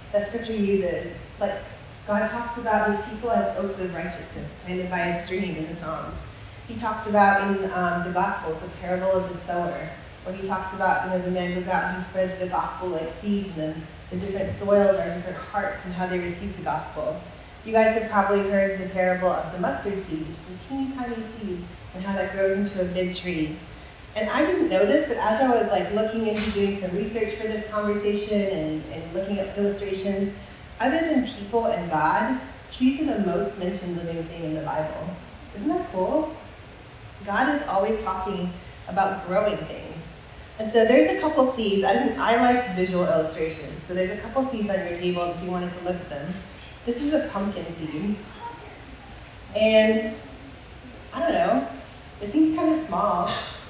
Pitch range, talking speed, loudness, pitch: 180-220 Hz, 195 wpm, -25 LUFS, 195 Hz